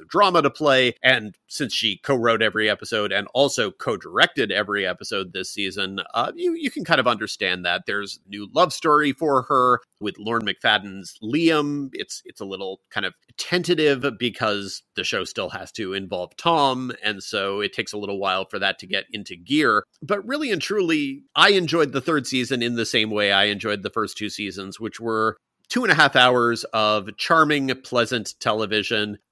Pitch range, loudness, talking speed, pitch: 105-150 Hz, -21 LUFS, 190 wpm, 120 Hz